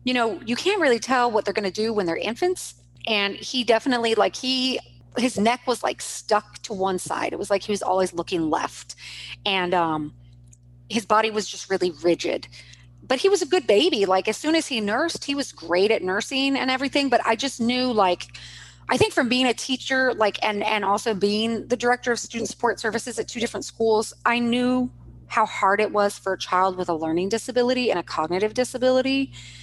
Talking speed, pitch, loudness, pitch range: 215 wpm, 220 Hz, -23 LUFS, 185-250 Hz